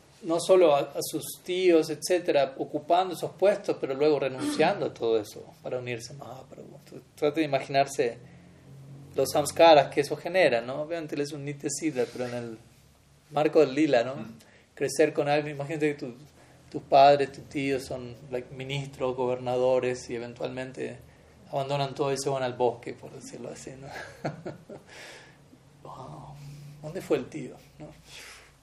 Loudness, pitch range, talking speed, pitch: -27 LUFS, 130-150 Hz, 155 wpm, 140 Hz